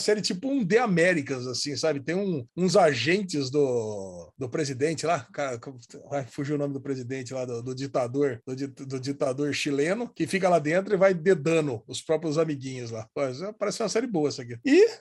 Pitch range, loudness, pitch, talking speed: 135-185 Hz, -27 LUFS, 150 Hz, 190 wpm